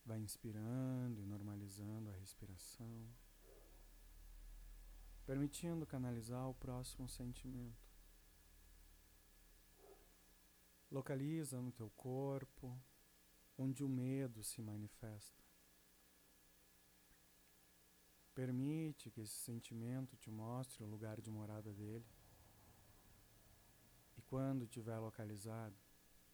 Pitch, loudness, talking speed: 105 Hz, -49 LUFS, 80 wpm